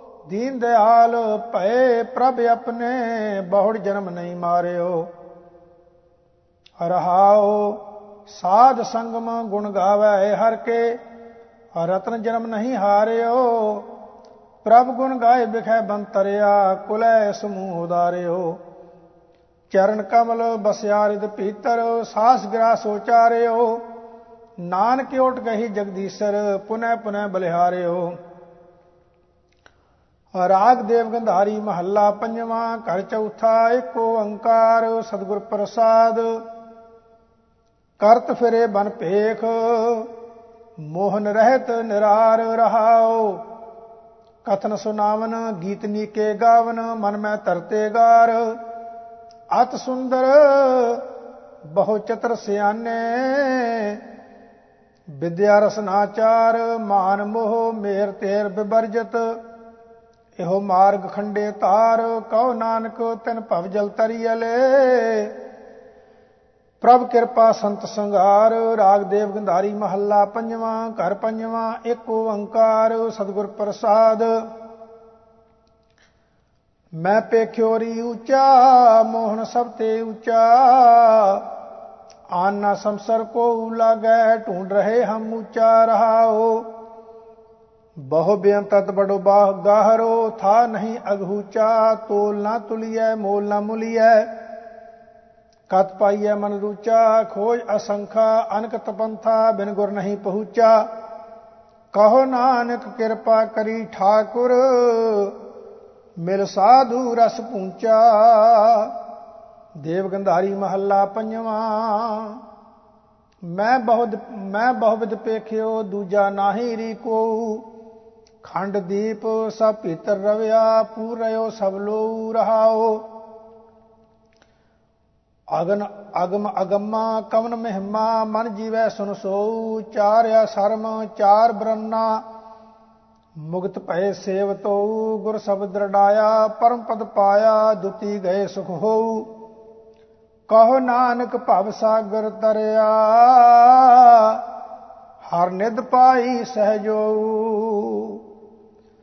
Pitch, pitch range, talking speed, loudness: 220 Hz, 205-230 Hz, 85 wpm, -18 LUFS